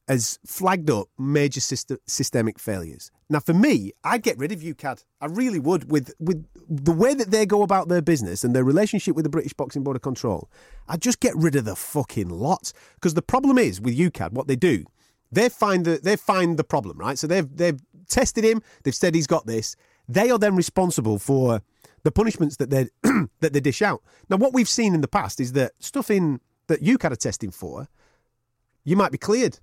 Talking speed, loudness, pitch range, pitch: 215 wpm, -23 LUFS, 130-190 Hz, 155 Hz